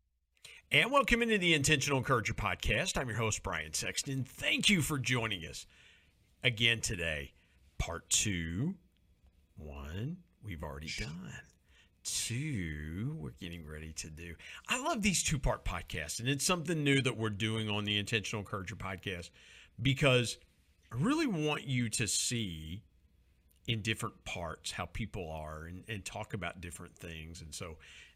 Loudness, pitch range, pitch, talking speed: -33 LUFS, 80-125 Hz, 100 Hz, 150 wpm